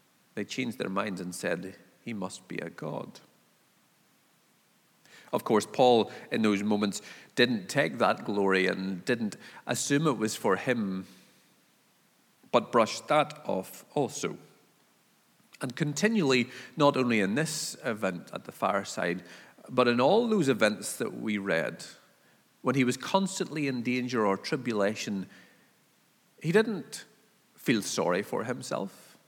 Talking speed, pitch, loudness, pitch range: 135 wpm, 120 Hz, -29 LUFS, 100-145 Hz